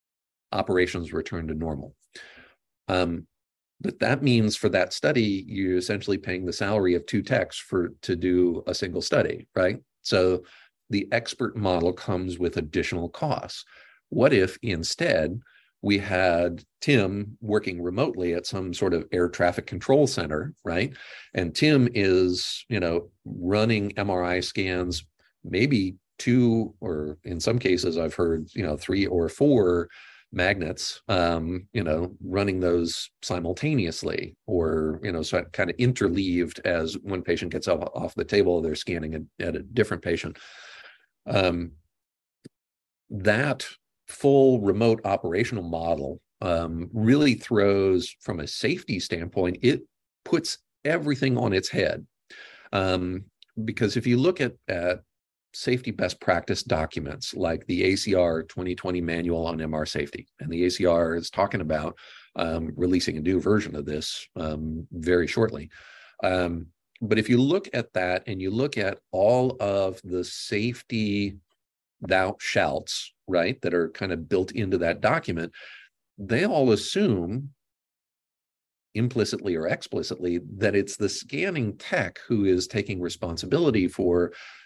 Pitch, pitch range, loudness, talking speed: 90 Hz, 85-110 Hz, -26 LUFS, 140 wpm